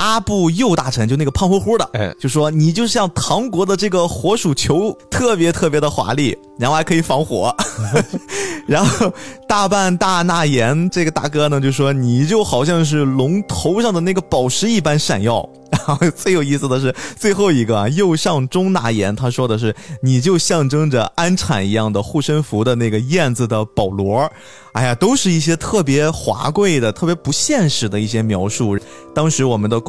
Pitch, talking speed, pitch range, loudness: 150 Hz, 275 characters per minute, 125-185 Hz, -16 LUFS